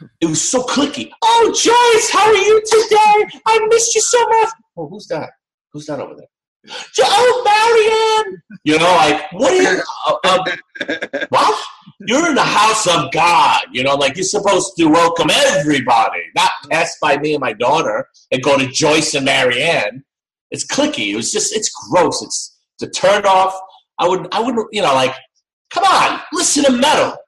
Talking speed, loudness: 180 wpm, -14 LUFS